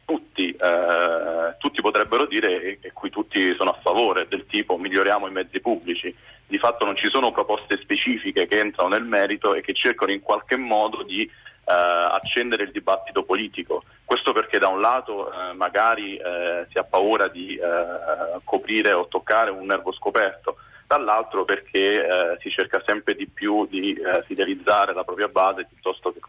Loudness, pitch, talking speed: -22 LUFS, 315 Hz, 175 wpm